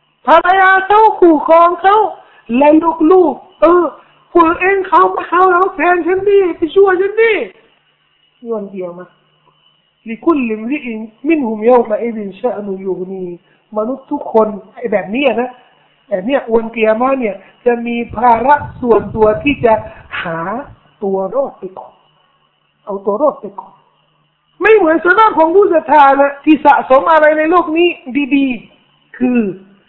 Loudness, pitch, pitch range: -12 LUFS, 270 Hz, 220-335 Hz